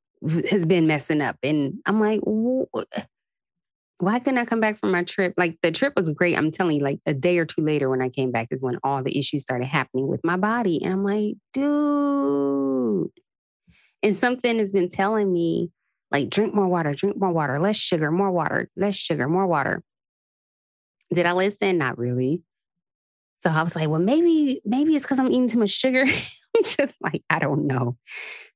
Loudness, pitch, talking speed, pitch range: -23 LUFS, 180 Hz, 200 wpm, 150-215 Hz